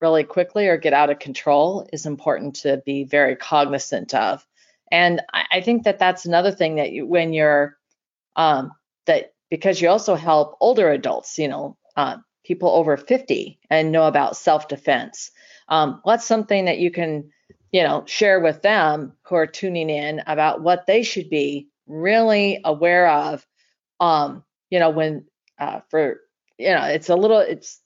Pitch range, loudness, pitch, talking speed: 150-185 Hz, -19 LUFS, 160 Hz, 170 wpm